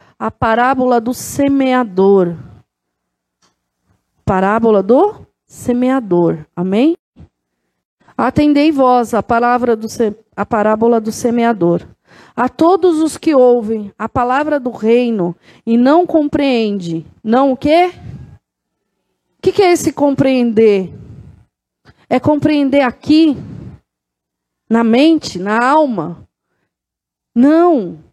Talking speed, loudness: 100 wpm, -13 LUFS